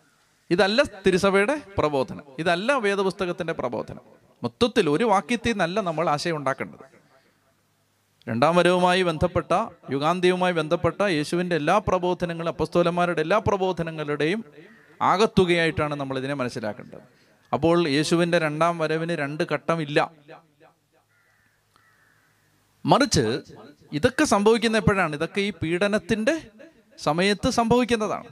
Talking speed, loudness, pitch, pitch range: 95 wpm, -23 LUFS, 175 Hz, 160-205 Hz